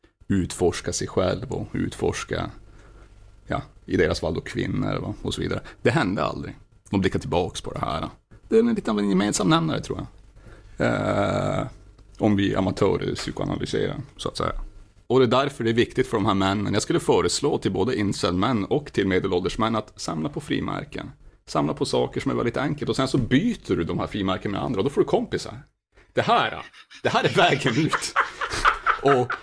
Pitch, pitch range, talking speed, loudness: 105 Hz, 100-125 Hz, 190 wpm, -24 LUFS